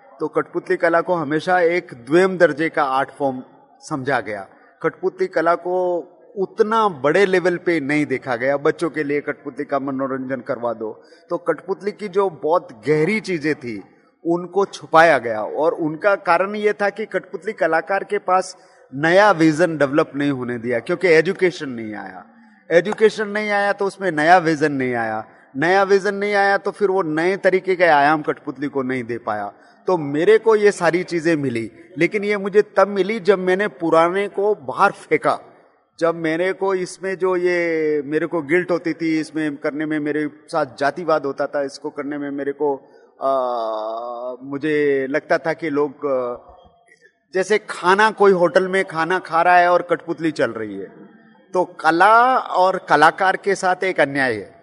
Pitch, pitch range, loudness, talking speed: 170 Hz, 145-190 Hz, -19 LUFS, 175 wpm